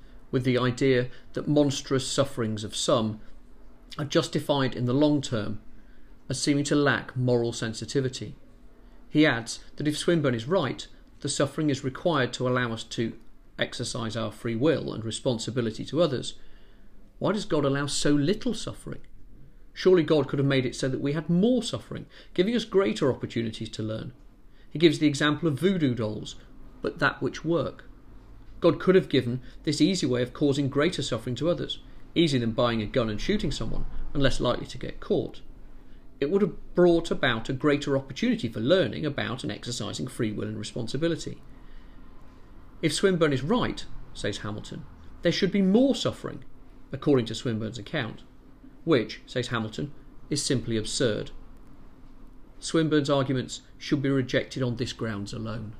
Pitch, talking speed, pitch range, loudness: 135 Hz, 165 wpm, 115-150 Hz, -27 LUFS